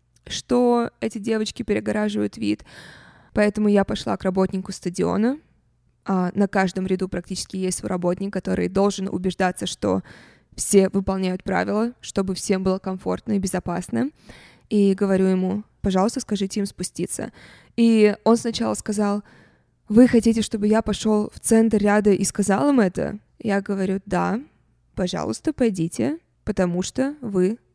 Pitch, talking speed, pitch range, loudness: 200 Hz, 135 wpm, 190-220 Hz, -22 LUFS